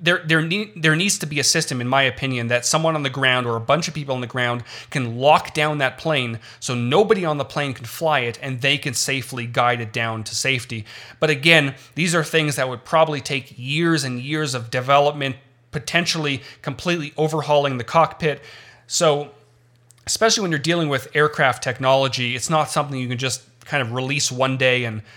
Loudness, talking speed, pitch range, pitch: -20 LUFS, 205 wpm, 125-155 Hz, 140 Hz